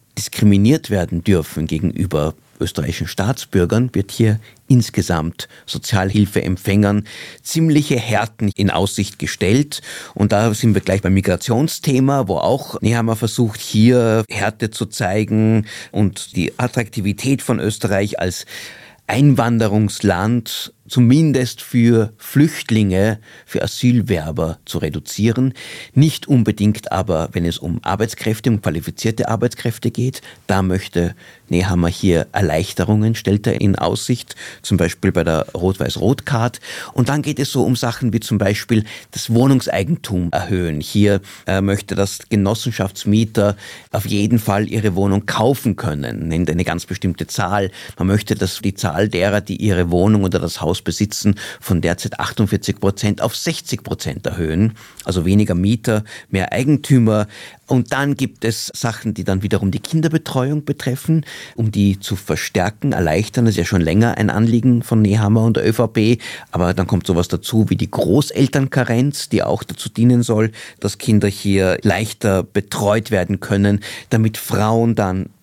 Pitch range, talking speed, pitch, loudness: 95-120 Hz, 140 wpm, 105 Hz, -18 LUFS